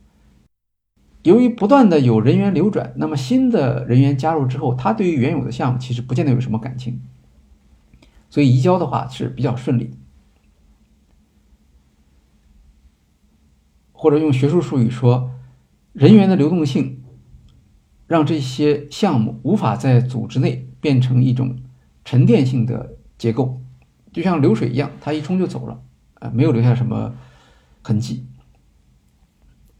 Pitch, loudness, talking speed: 125 Hz, -17 LUFS, 215 characters per minute